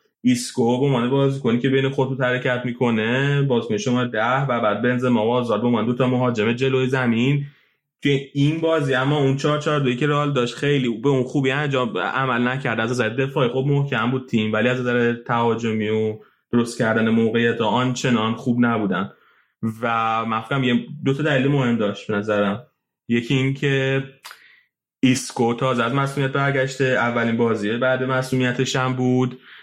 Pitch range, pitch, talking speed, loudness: 120-135 Hz, 125 Hz, 170 wpm, -21 LUFS